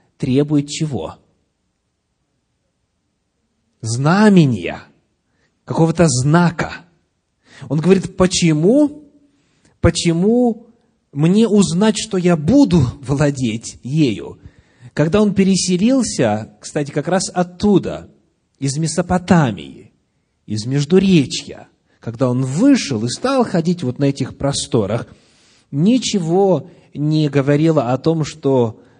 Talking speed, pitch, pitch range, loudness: 90 wpm, 160 Hz, 130-190 Hz, -16 LUFS